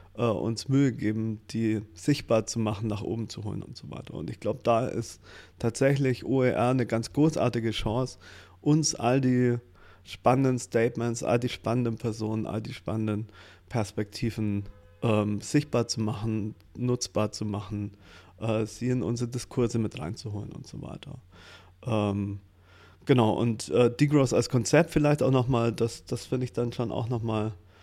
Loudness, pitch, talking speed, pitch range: -28 LUFS, 115 Hz, 155 wpm, 105-125 Hz